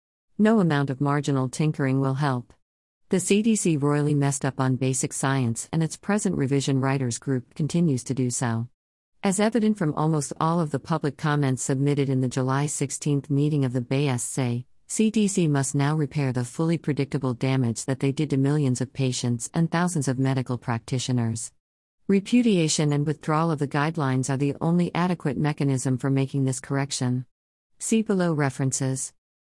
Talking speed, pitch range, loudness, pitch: 165 wpm, 130-155 Hz, -25 LUFS, 140 Hz